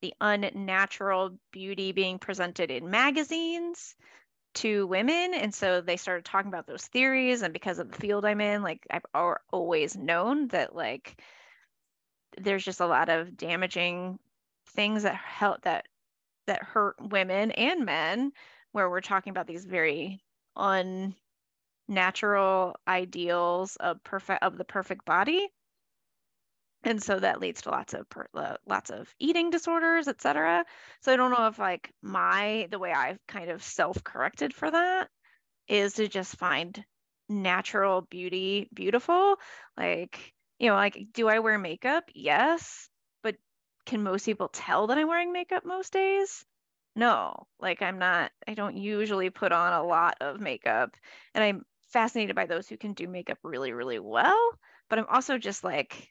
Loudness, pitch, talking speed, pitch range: -28 LUFS, 205 Hz, 155 wpm, 185-250 Hz